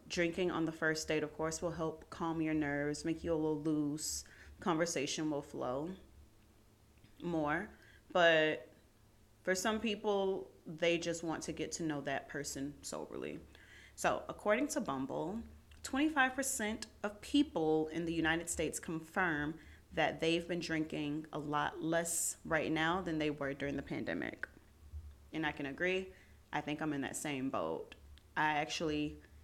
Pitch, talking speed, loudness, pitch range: 155 Hz, 155 wpm, -37 LUFS, 140-170 Hz